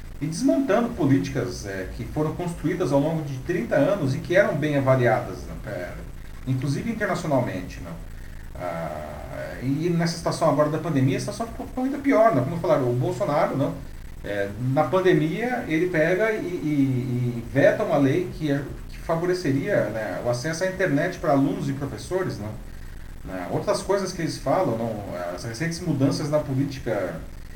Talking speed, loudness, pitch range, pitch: 170 wpm, -24 LUFS, 115-170 Hz, 140 Hz